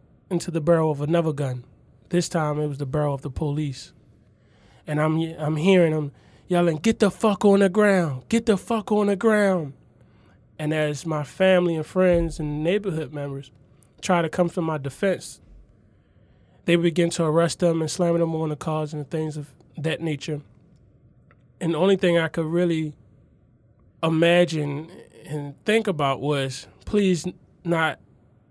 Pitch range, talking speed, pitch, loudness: 140-175 Hz, 165 wpm, 155 Hz, -23 LUFS